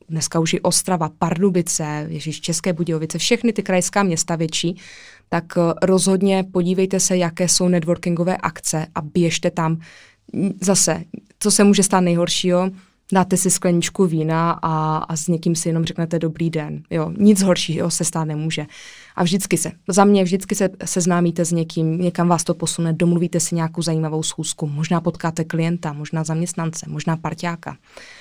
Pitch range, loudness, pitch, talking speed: 165-185 Hz, -19 LUFS, 170 Hz, 160 wpm